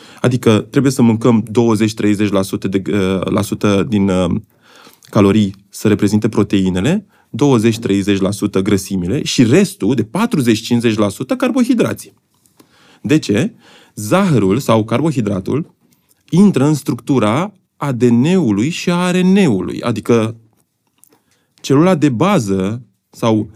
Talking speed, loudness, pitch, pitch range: 100 wpm, -15 LUFS, 115 Hz, 105-150 Hz